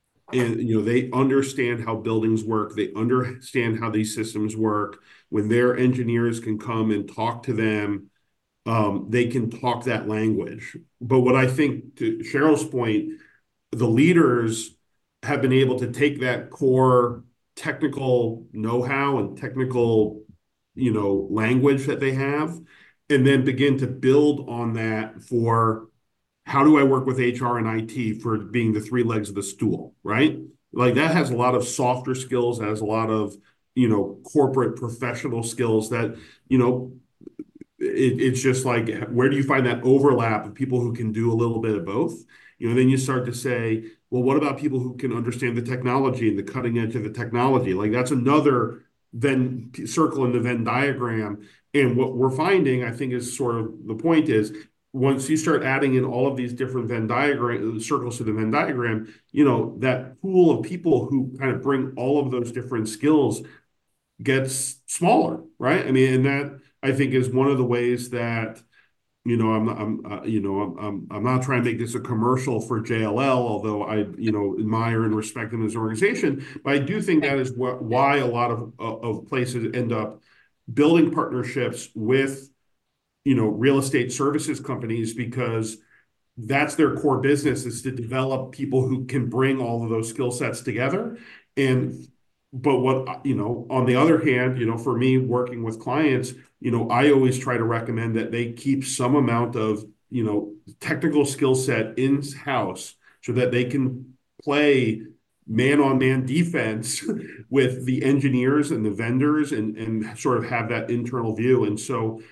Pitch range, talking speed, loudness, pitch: 115-135 Hz, 185 wpm, -23 LUFS, 125 Hz